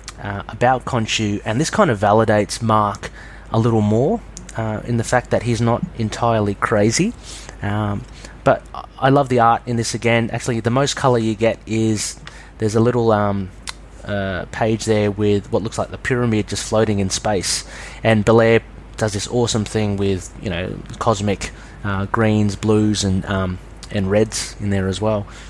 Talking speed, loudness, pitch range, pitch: 175 wpm, -19 LUFS, 100-115 Hz, 110 Hz